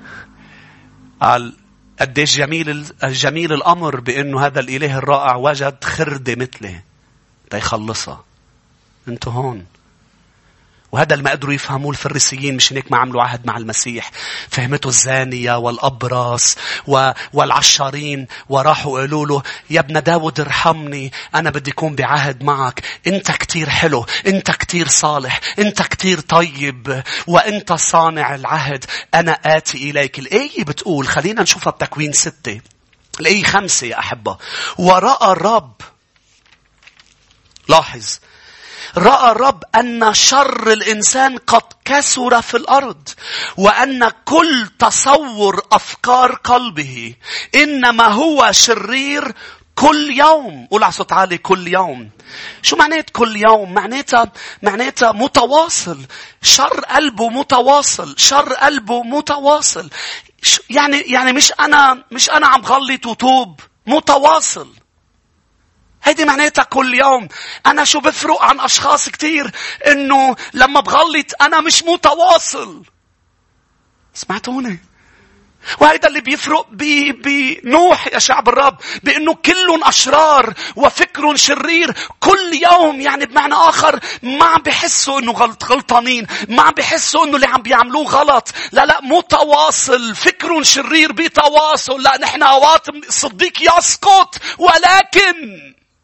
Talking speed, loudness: 115 wpm, -12 LUFS